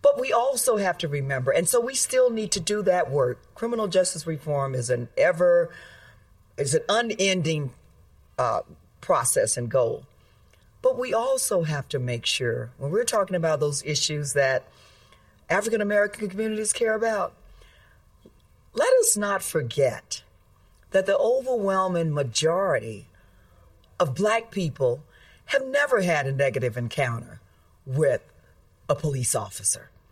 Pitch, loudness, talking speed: 155 Hz, -24 LUFS, 135 wpm